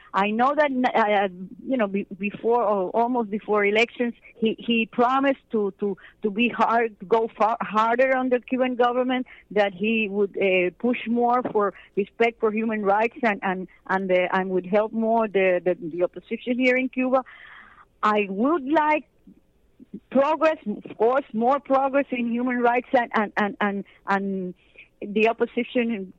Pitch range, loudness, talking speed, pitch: 200-250 Hz, -23 LUFS, 155 wpm, 225 Hz